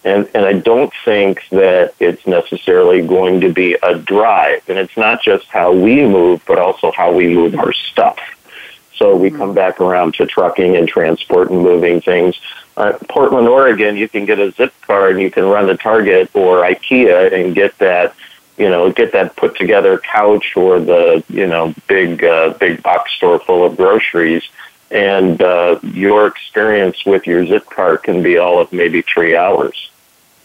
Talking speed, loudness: 180 wpm, -11 LUFS